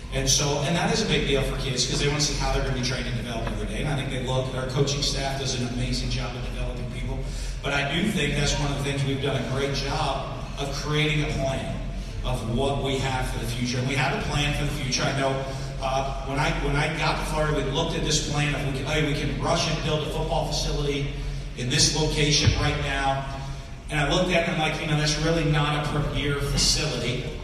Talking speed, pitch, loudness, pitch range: 265 wpm, 140 Hz, -25 LUFS, 135-150 Hz